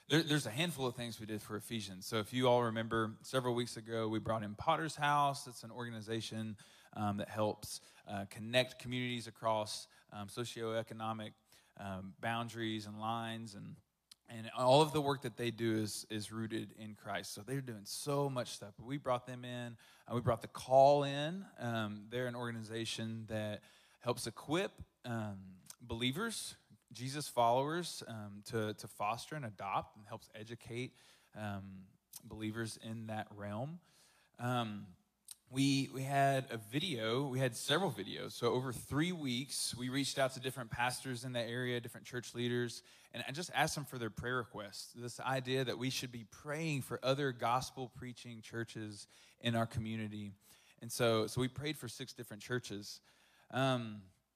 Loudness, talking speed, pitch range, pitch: -38 LUFS, 170 wpm, 110-130 Hz, 120 Hz